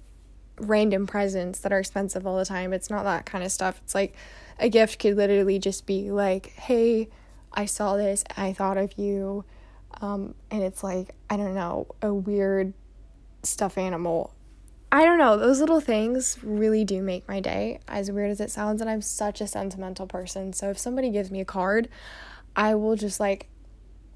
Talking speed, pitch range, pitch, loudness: 185 wpm, 190-215 Hz, 200 Hz, -26 LUFS